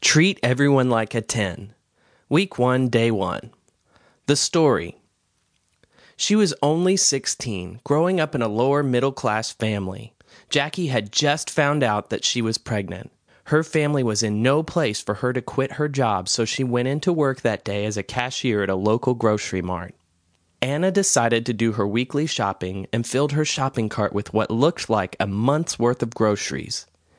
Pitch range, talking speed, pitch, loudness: 105-145 Hz, 175 wpm, 120 Hz, -22 LUFS